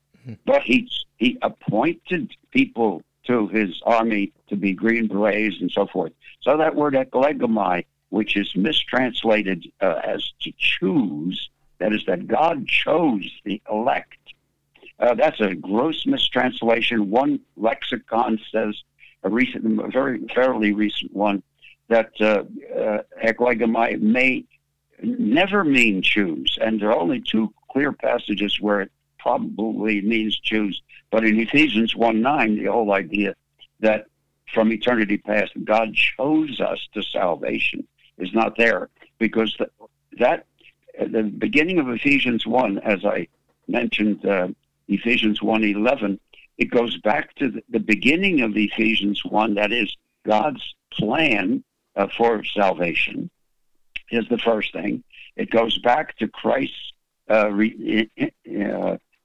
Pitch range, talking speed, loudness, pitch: 105-125 Hz, 135 wpm, -21 LUFS, 110 Hz